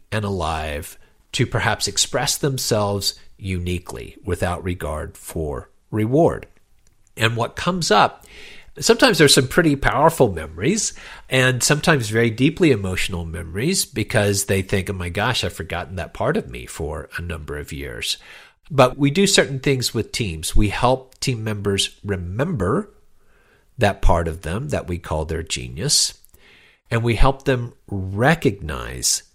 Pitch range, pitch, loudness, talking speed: 90-130 Hz, 105 Hz, -20 LUFS, 145 wpm